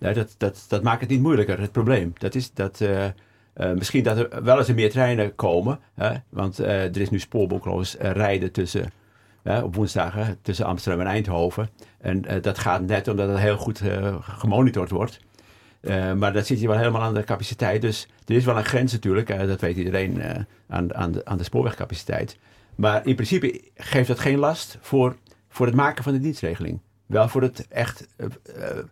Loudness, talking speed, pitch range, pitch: -23 LUFS, 205 wpm, 100-120 Hz, 105 Hz